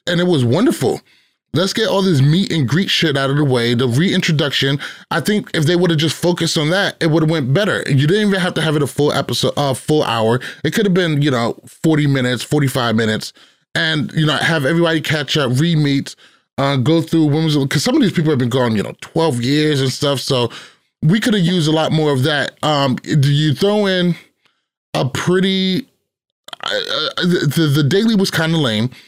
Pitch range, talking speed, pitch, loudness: 140-175 Hz, 225 wpm, 155 Hz, -16 LUFS